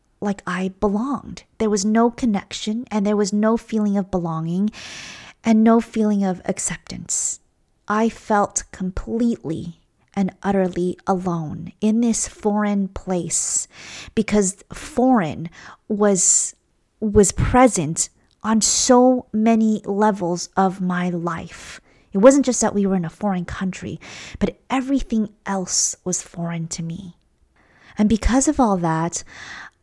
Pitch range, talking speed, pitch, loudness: 180-220 Hz, 125 wpm, 205 Hz, -20 LUFS